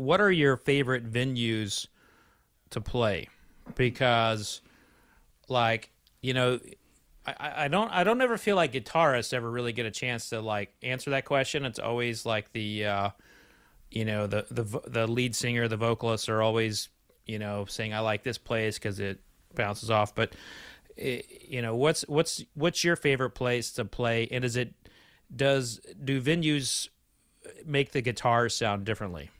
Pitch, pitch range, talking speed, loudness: 120 Hz, 110-135 Hz, 160 wpm, -29 LUFS